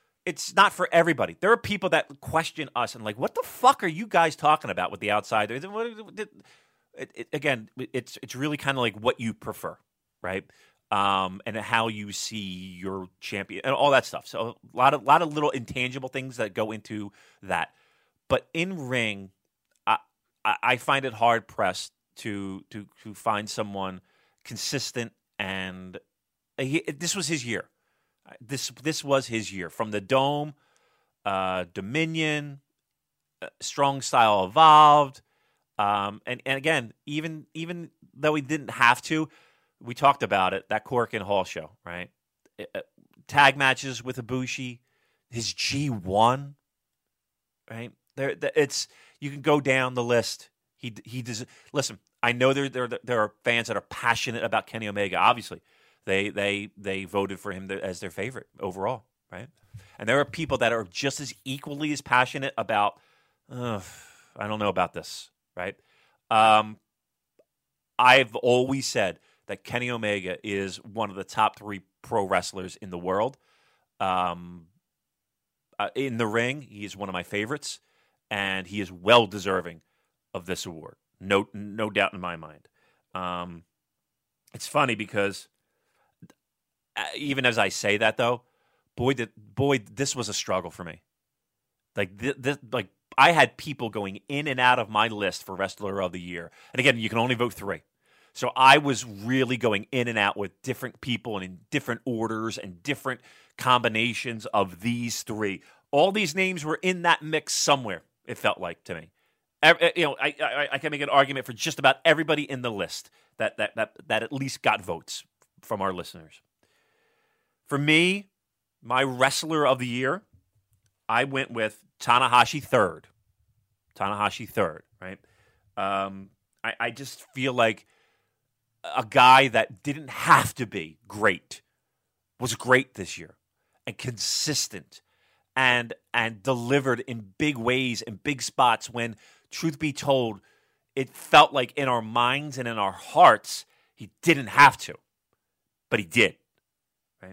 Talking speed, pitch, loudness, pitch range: 160 wpm, 120 Hz, -25 LUFS, 105-140 Hz